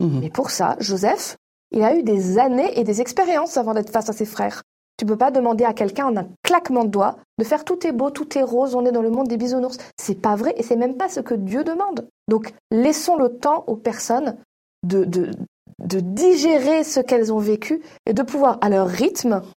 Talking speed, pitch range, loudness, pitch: 230 wpm, 215-280 Hz, -20 LUFS, 240 Hz